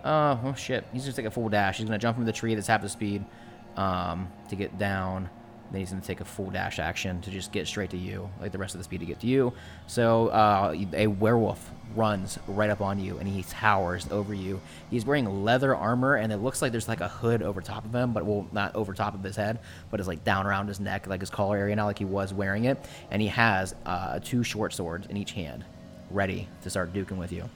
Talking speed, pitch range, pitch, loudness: 265 wpm, 95-115 Hz, 100 Hz, -29 LUFS